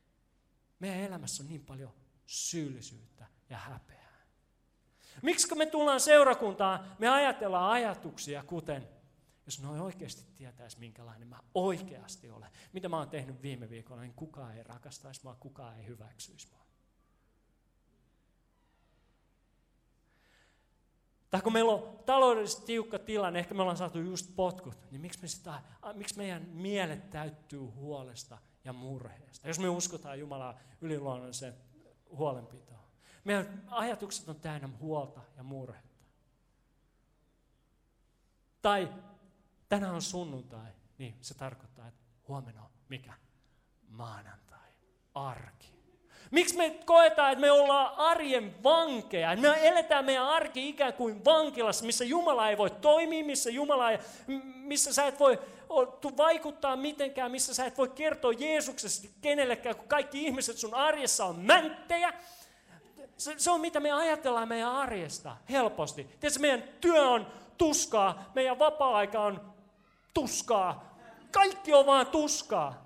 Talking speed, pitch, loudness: 125 wpm, 195 Hz, -29 LUFS